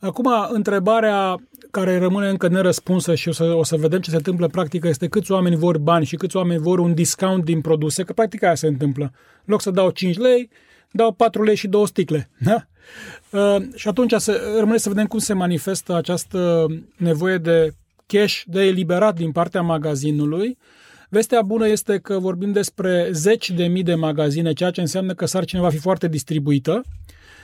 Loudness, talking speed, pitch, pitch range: -19 LUFS, 190 wpm, 185 Hz, 165-205 Hz